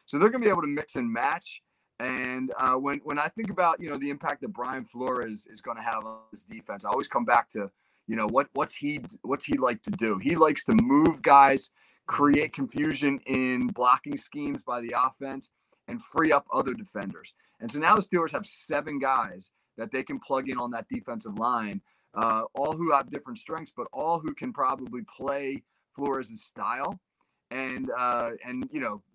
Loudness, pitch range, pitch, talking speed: -27 LUFS, 130-175 Hz, 140 Hz, 210 wpm